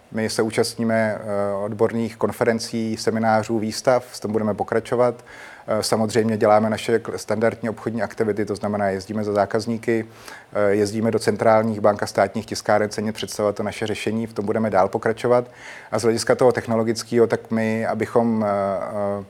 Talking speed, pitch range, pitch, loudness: 145 wpm, 105-115 Hz, 110 Hz, -21 LUFS